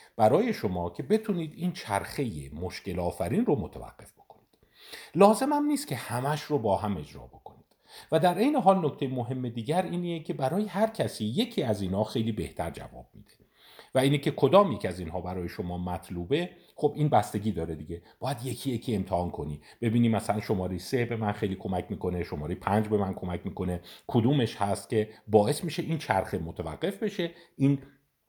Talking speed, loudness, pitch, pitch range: 180 wpm, -29 LUFS, 115 Hz, 95-150 Hz